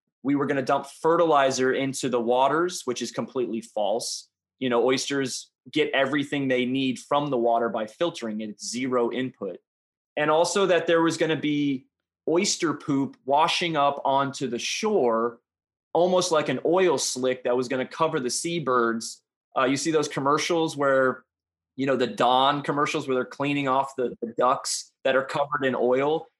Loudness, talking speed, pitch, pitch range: -25 LUFS, 180 wpm, 135 Hz, 125-150 Hz